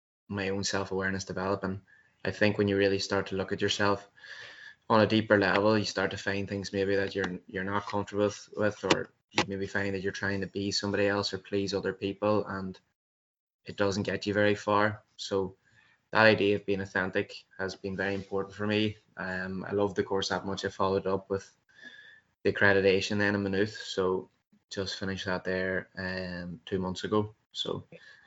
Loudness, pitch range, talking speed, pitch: -30 LUFS, 95-100 Hz, 190 wpm, 100 Hz